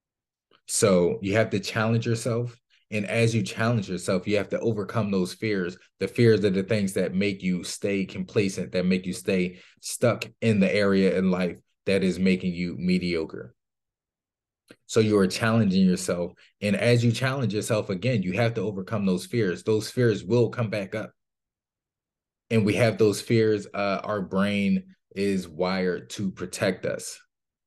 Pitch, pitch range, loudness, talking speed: 100 Hz, 95-115 Hz, -25 LUFS, 170 wpm